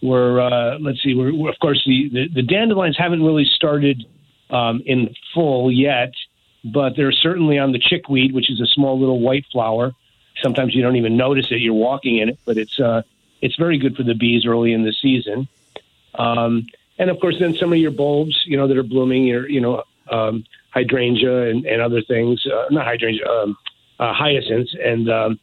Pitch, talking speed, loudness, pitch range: 130 Hz, 205 wpm, -17 LUFS, 115-140 Hz